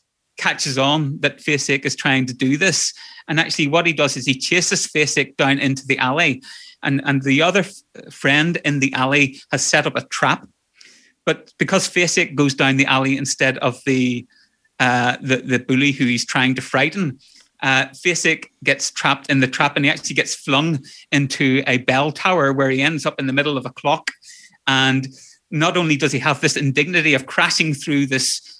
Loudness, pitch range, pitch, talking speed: -18 LUFS, 135-155 Hz, 140 Hz, 195 wpm